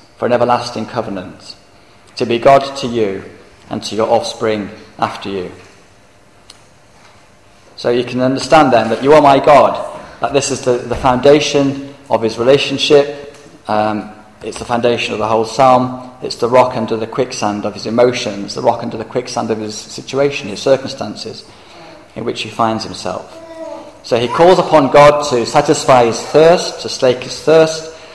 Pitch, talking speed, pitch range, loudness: 120 Hz, 170 wpm, 110-140 Hz, -13 LUFS